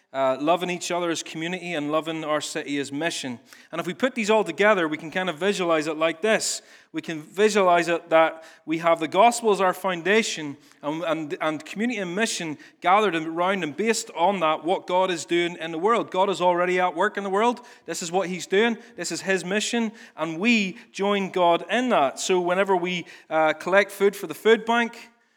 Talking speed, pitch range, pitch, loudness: 215 wpm, 160-205 Hz, 180 Hz, -23 LUFS